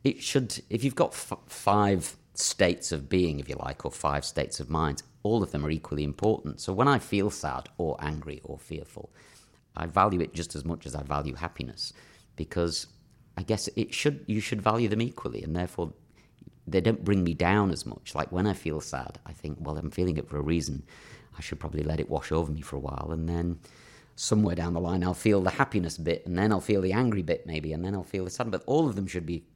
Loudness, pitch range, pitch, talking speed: -29 LUFS, 80-105 Hz, 85 Hz, 240 wpm